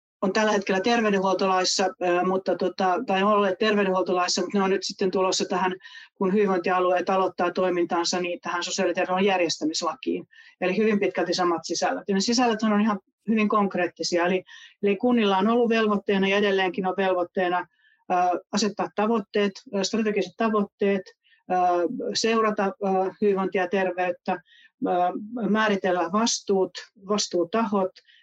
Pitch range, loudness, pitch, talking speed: 180-210 Hz, -24 LUFS, 190 Hz, 125 wpm